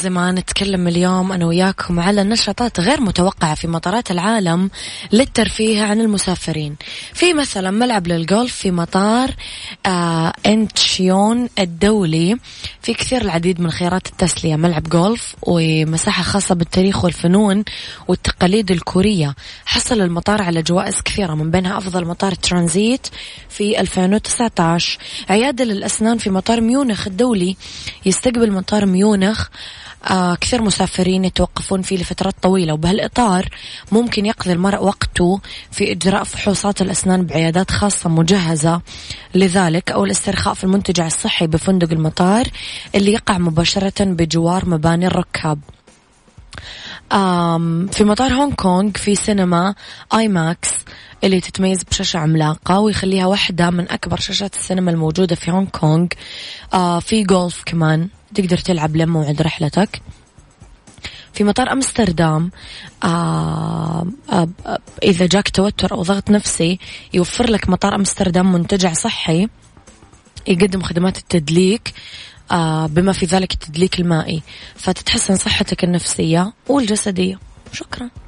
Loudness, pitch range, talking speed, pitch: -16 LUFS, 170-205 Hz, 120 wpm, 185 Hz